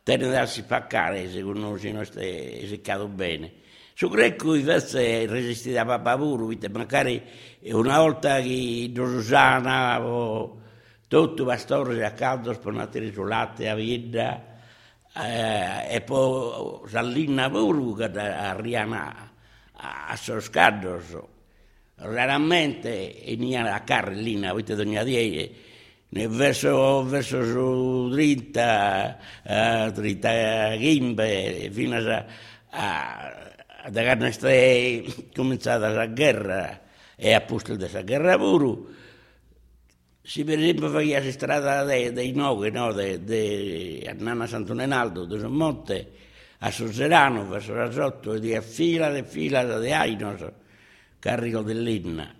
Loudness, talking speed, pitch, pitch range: -24 LUFS, 135 wpm, 115 Hz, 105-130 Hz